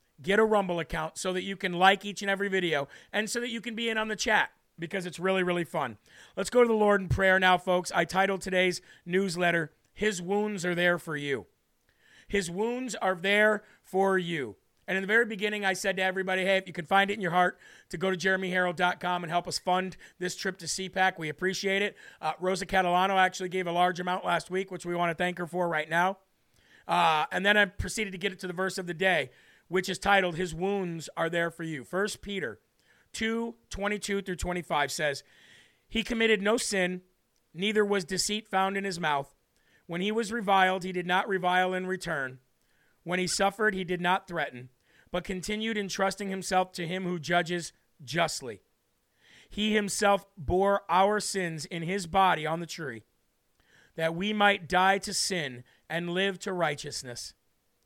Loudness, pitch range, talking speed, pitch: -28 LUFS, 175-200 Hz, 200 wpm, 185 Hz